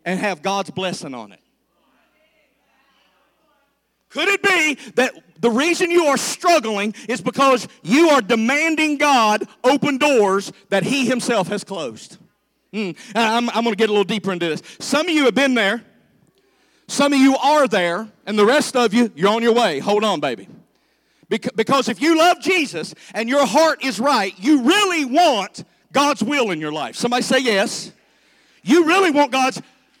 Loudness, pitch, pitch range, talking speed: -18 LUFS, 250 Hz, 210-290 Hz, 170 wpm